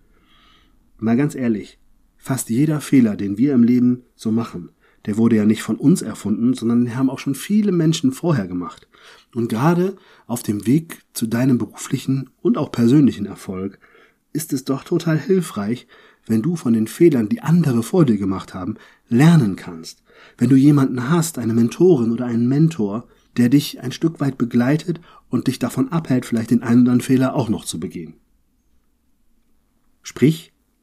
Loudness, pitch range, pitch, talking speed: -19 LUFS, 115-155 Hz, 125 Hz, 170 wpm